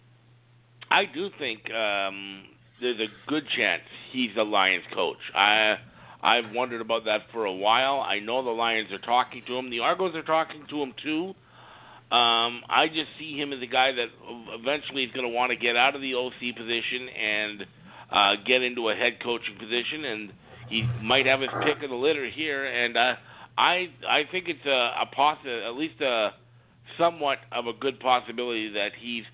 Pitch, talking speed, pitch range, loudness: 120 Hz, 190 wpm, 115-135 Hz, -26 LUFS